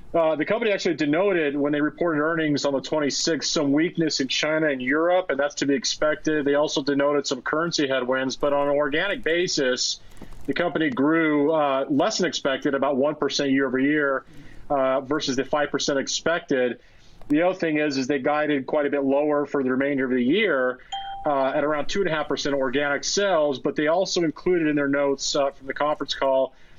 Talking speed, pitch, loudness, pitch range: 205 wpm, 145 Hz, -23 LUFS, 140-155 Hz